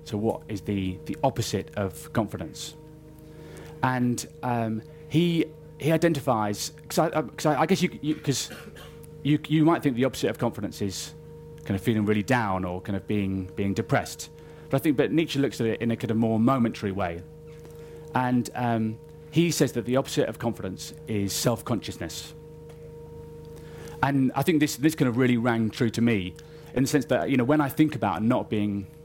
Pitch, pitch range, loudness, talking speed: 130 Hz, 110-155 Hz, -26 LUFS, 190 wpm